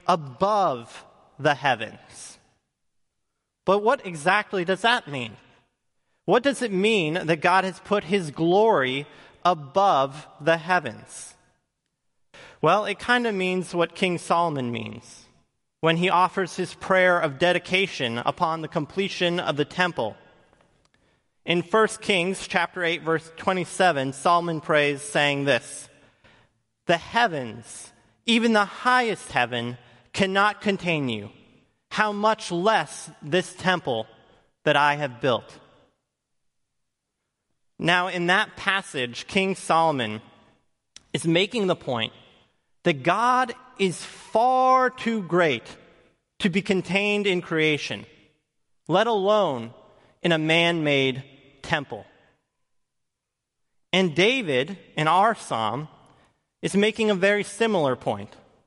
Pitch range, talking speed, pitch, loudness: 145-195 Hz, 115 wpm, 175 Hz, -23 LUFS